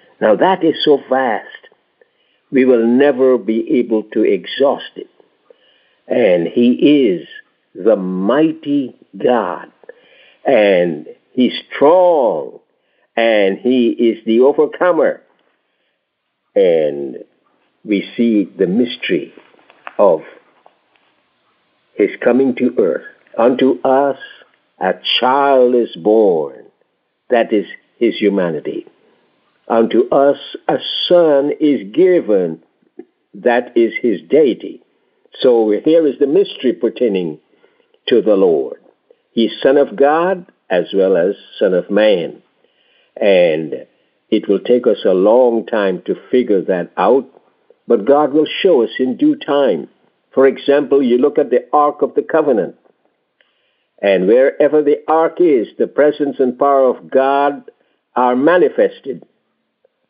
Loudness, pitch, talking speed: -14 LUFS, 330 Hz, 120 wpm